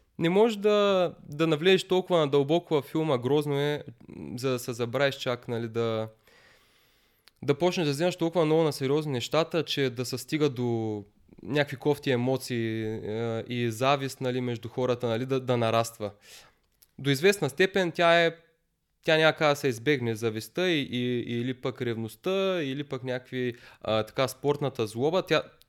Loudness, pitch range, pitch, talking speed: -27 LUFS, 120-160 Hz, 135 Hz, 155 wpm